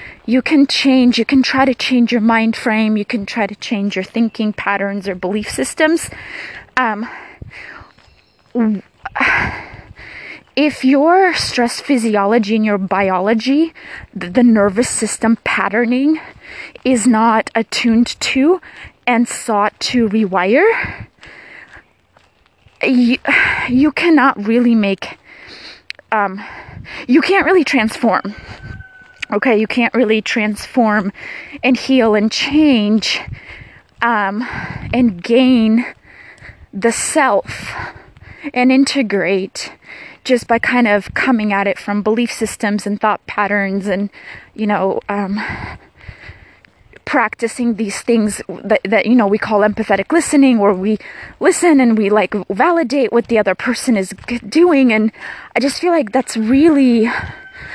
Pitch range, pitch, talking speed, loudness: 210-265 Hz, 230 Hz, 120 wpm, -15 LUFS